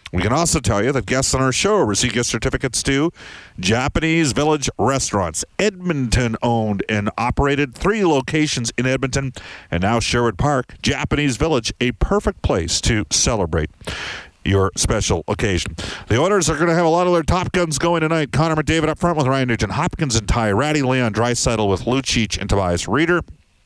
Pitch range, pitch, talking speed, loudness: 105-155 Hz, 125 Hz, 180 wpm, -19 LUFS